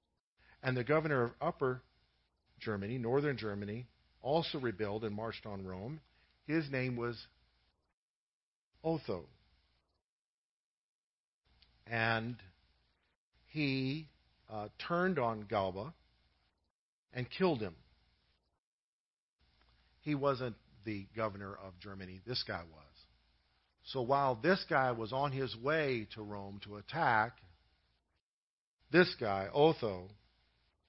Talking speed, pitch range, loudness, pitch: 100 wpm, 75-130 Hz, -36 LUFS, 105 Hz